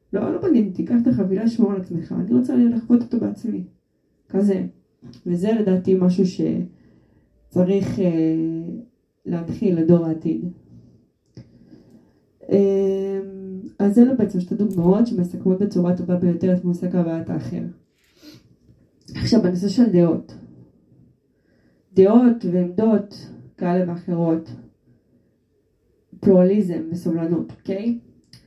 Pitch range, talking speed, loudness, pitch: 170-205 Hz, 95 wpm, -20 LUFS, 185 Hz